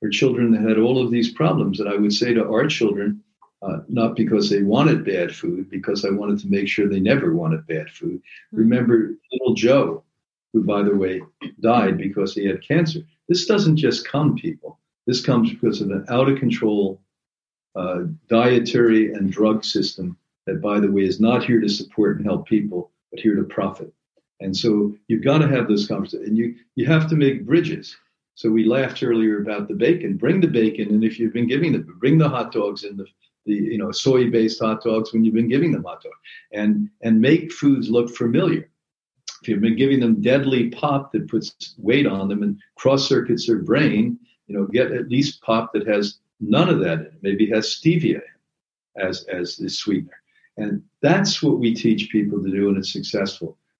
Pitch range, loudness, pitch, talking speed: 105-135 Hz, -20 LUFS, 115 Hz, 205 wpm